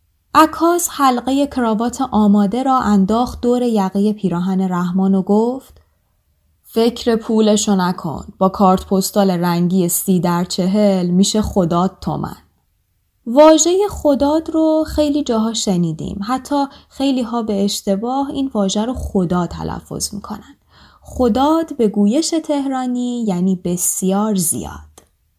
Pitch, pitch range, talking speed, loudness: 210 Hz, 190-260 Hz, 120 wpm, -16 LUFS